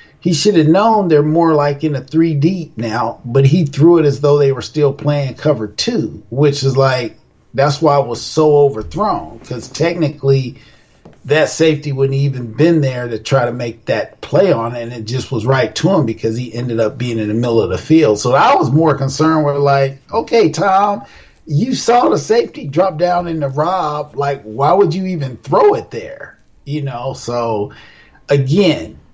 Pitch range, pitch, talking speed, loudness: 120-160 Hz, 140 Hz, 200 wpm, -14 LUFS